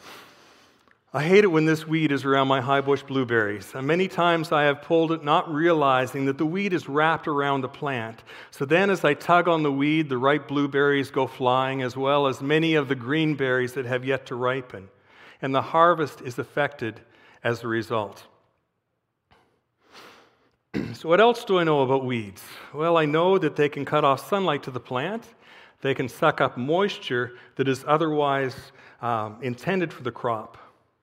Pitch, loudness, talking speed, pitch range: 140 Hz, -23 LUFS, 185 wpm, 130-160 Hz